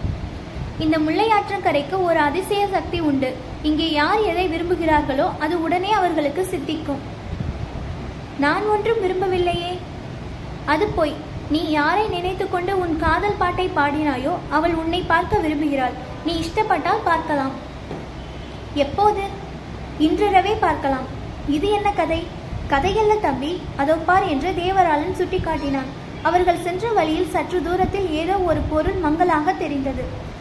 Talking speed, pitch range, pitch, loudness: 110 wpm, 305-375 Hz, 345 Hz, -21 LUFS